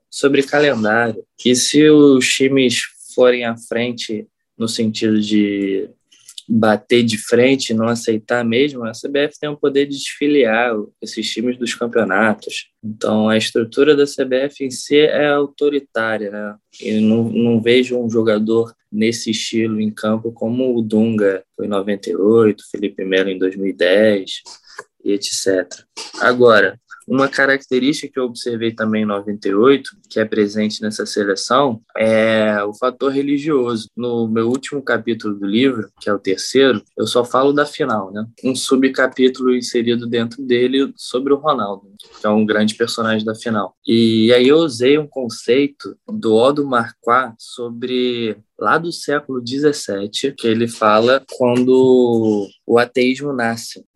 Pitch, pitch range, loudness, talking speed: 115 Hz, 110-130 Hz, -16 LUFS, 145 wpm